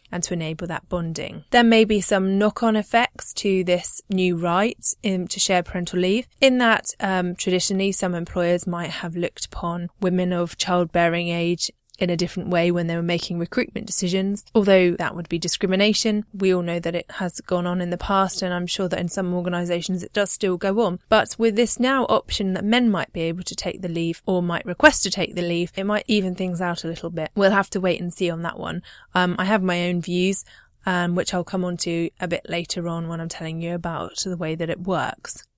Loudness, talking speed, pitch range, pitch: -22 LUFS, 230 wpm, 175-195 Hz, 180 Hz